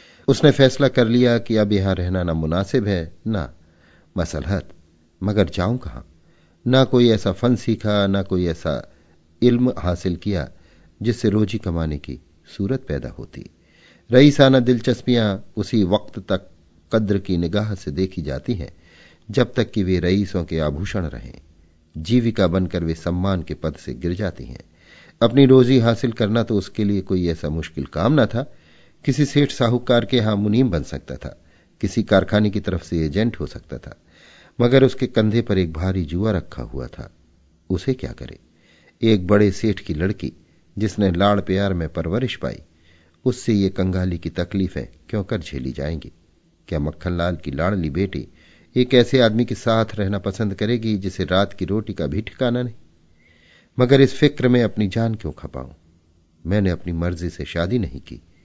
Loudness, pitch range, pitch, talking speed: -20 LUFS, 80-115 Hz, 95 Hz, 165 wpm